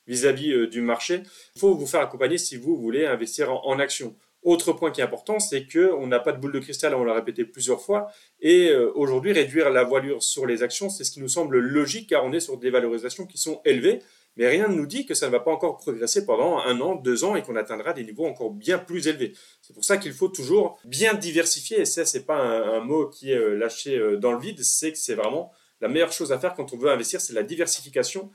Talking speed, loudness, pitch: 250 wpm, -24 LUFS, 190 Hz